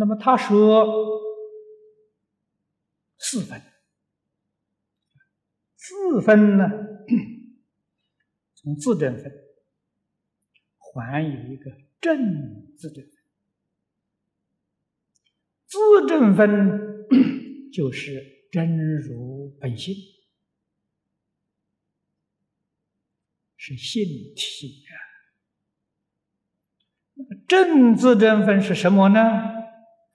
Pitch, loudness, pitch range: 210 Hz, -19 LUFS, 155-255 Hz